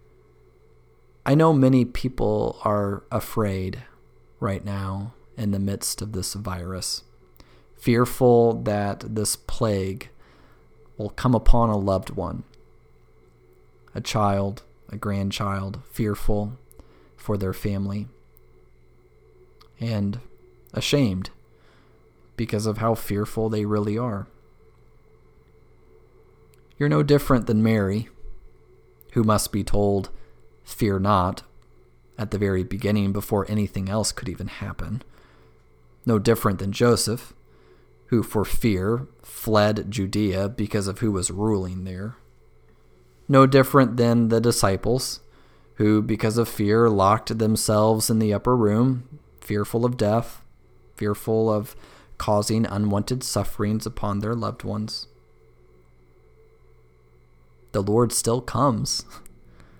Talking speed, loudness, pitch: 110 wpm, -23 LUFS, 100 Hz